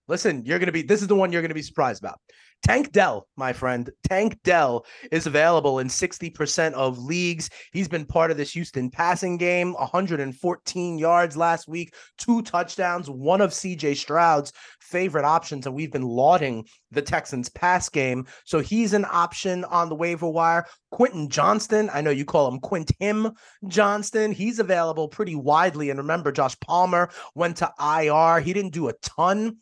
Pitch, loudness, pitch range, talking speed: 170 Hz, -23 LUFS, 150-185 Hz, 180 wpm